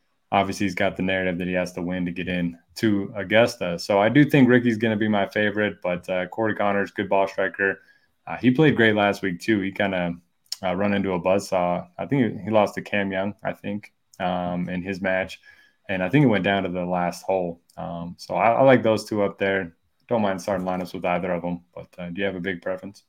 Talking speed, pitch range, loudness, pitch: 250 wpm, 90-105 Hz, -23 LUFS, 95 Hz